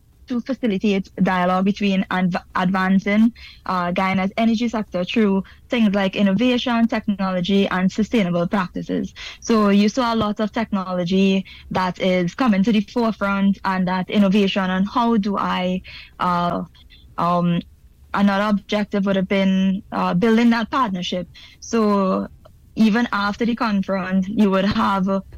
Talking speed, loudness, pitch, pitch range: 135 wpm, -20 LUFS, 195 Hz, 185-220 Hz